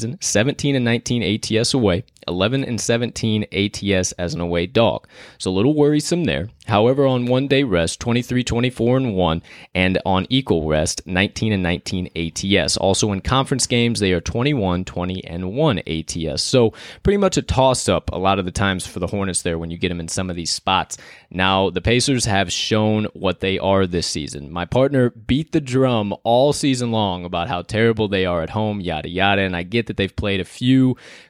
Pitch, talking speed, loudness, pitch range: 100 Hz, 200 wpm, -19 LUFS, 90-120 Hz